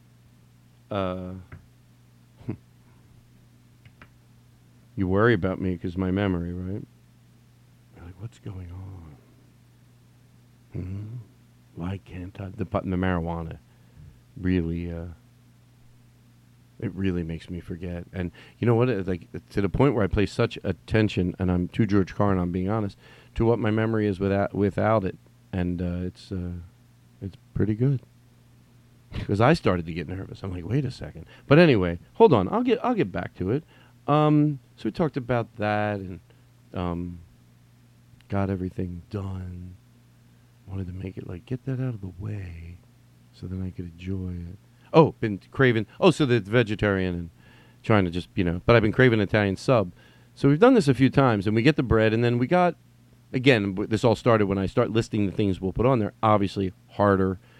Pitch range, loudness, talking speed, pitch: 90-120 Hz, -25 LUFS, 175 wpm, 105 Hz